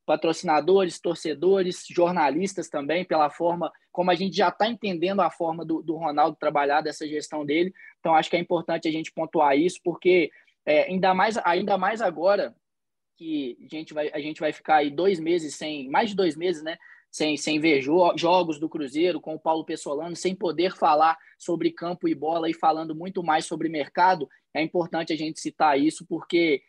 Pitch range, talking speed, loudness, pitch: 155-180 Hz, 190 wpm, -25 LUFS, 165 Hz